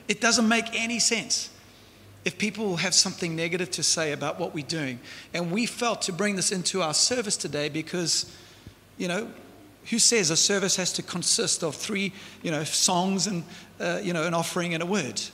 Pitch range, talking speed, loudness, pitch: 165-210 Hz, 195 wpm, -25 LUFS, 185 Hz